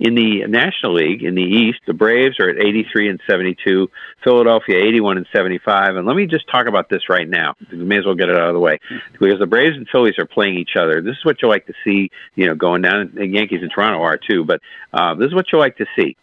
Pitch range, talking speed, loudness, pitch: 95-115 Hz, 265 wpm, -15 LUFS, 105 Hz